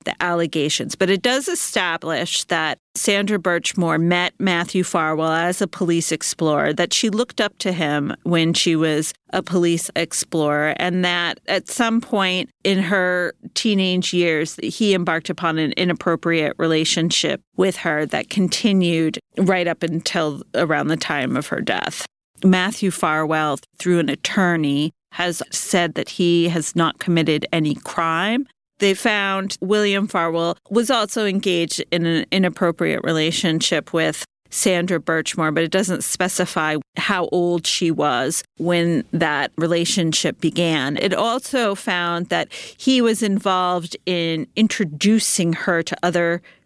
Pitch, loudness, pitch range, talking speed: 175 Hz, -20 LUFS, 165-195 Hz, 140 wpm